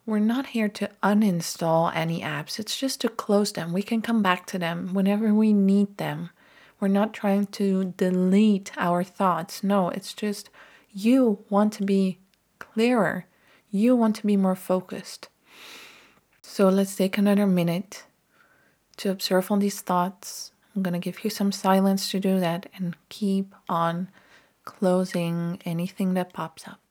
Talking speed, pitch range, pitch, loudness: 160 wpm, 180-210 Hz, 195 Hz, -25 LUFS